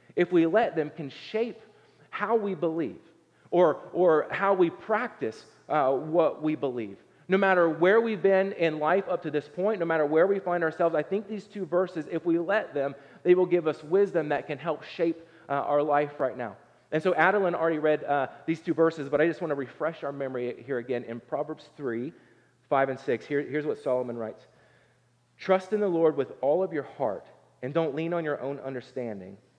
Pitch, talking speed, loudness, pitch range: 160 Hz, 210 wpm, -27 LUFS, 140-180 Hz